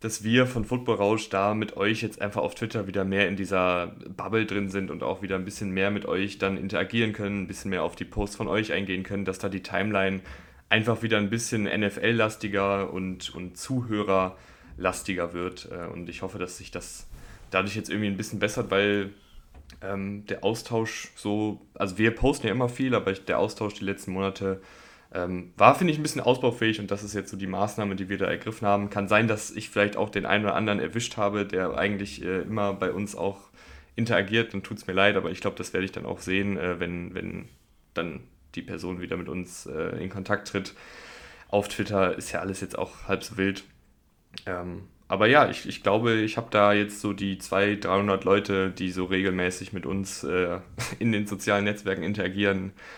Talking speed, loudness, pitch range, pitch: 210 wpm, -27 LUFS, 95-105 Hz, 100 Hz